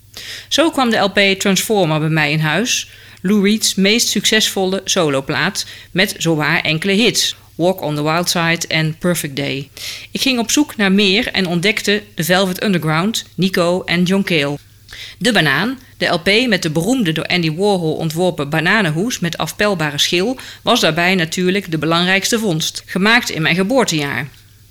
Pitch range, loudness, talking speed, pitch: 160-205 Hz, -15 LUFS, 160 wpm, 180 Hz